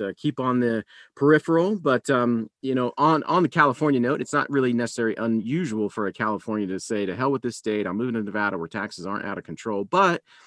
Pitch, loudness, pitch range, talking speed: 115 Hz, -24 LUFS, 105-135 Hz, 230 wpm